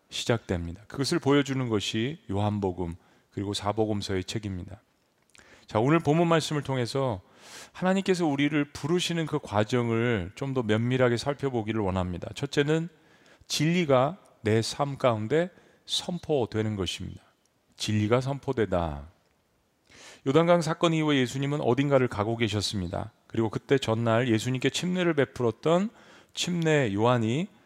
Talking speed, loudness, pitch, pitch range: 310 characters per minute, -27 LUFS, 125 Hz, 105-145 Hz